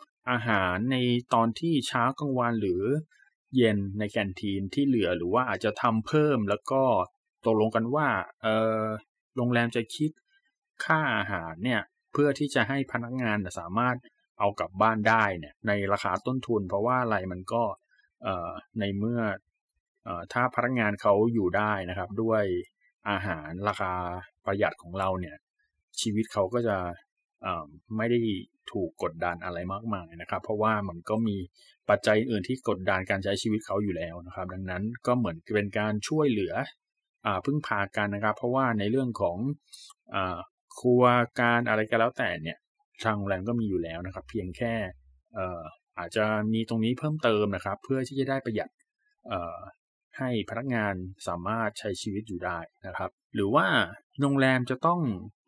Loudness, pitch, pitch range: -29 LUFS, 110 Hz, 100-125 Hz